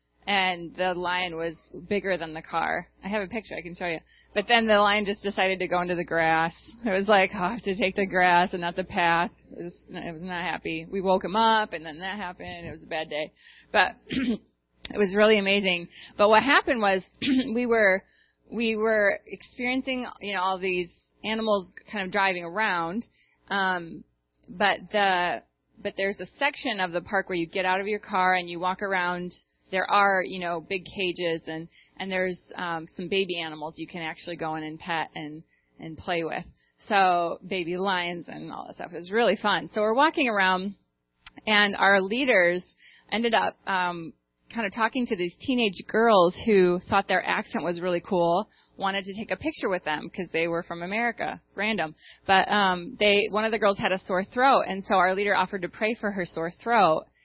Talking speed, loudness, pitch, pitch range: 210 wpm, -25 LUFS, 190 Hz, 175-210 Hz